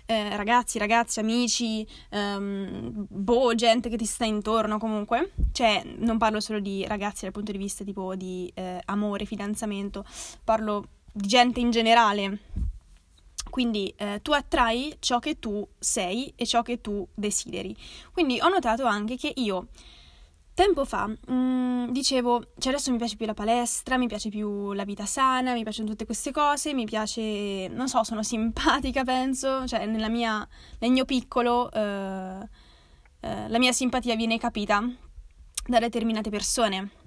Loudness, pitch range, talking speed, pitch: -26 LUFS, 205-245 Hz, 155 wpm, 225 Hz